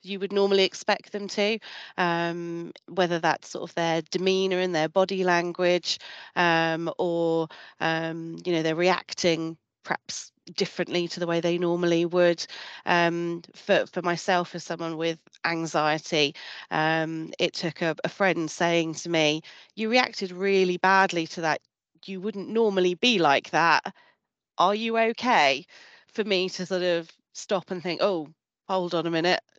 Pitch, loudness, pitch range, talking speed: 175 Hz, -25 LUFS, 165-190 Hz, 155 wpm